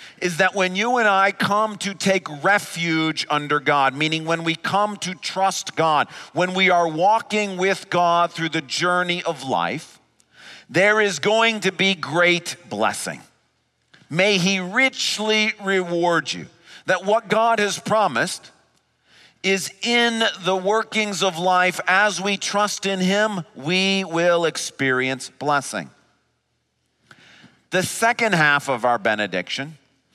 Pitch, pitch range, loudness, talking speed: 185 Hz, 160-205 Hz, -20 LUFS, 135 wpm